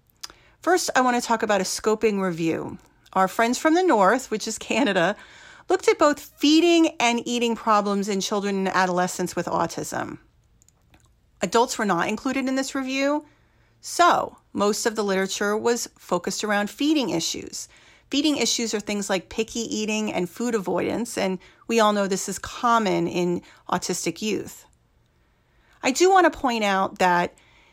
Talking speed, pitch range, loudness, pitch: 160 wpm, 190-260 Hz, -23 LUFS, 215 Hz